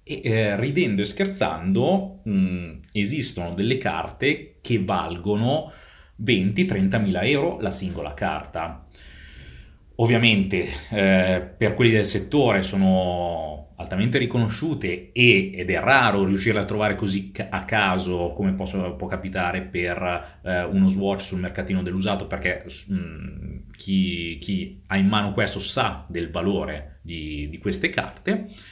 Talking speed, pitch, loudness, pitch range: 130 wpm, 95 Hz, -23 LUFS, 90-105 Hz